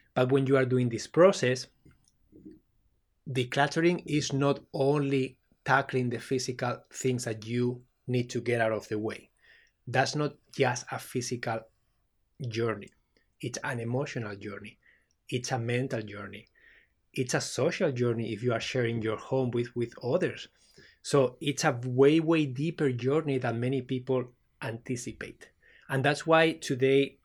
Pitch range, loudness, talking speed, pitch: 120-140 Hz, -29 LUFS, 145 wpm, 125 Hz